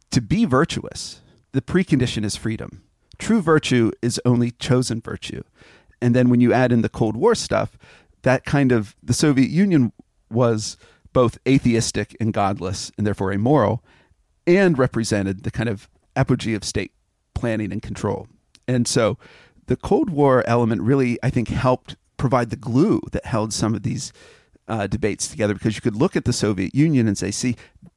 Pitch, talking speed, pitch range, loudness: 120 Hz, 170 wpm, 105-130 Hz, -21 LUFS